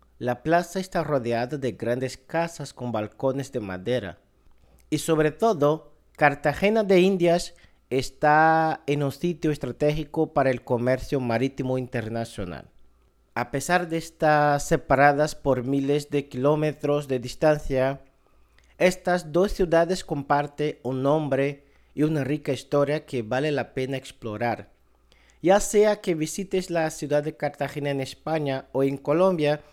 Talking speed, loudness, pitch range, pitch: 135 wpm, -25 LUFS, 130-160 Hz, 145 Hz